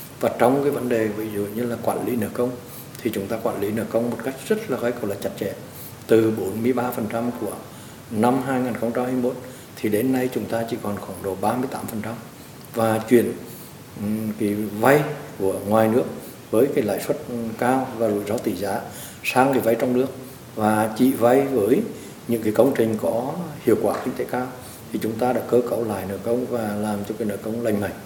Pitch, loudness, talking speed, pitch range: 115 Hz, -23 LUFS, 205 wpm, 110-125 Hz